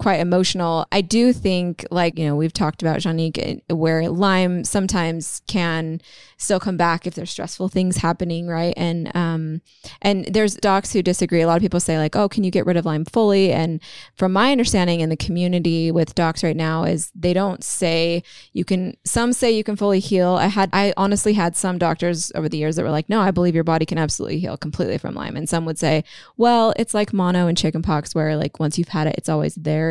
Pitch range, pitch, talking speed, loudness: 165-195 Hz, 175 Hz, 225 wpm, -20 LUFS